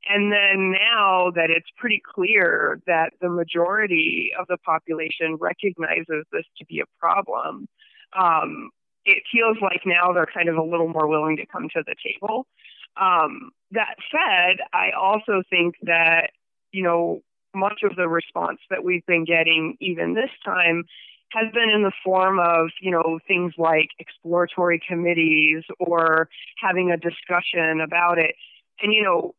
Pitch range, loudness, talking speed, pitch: 165-200 Hz, -21 LUFS, 155 wpm, 175 Hz